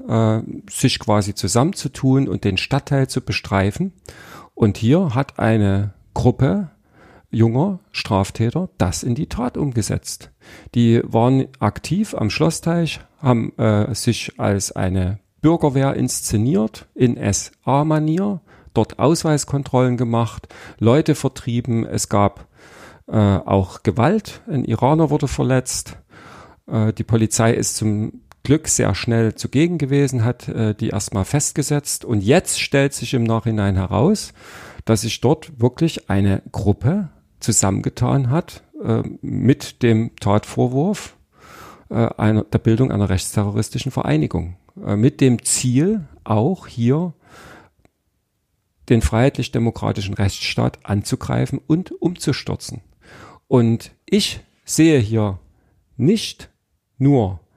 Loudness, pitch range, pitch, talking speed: -19 LUFS, 105-140 Hz, 115 Hz, 115 wpm